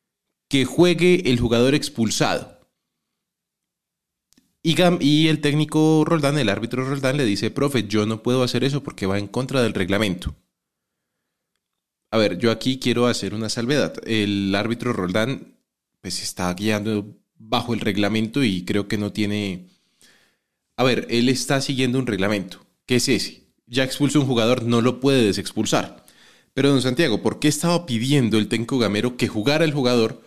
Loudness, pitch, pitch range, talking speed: -21 LUFS, 120 Hz, 105-140 Hz, 160 wpm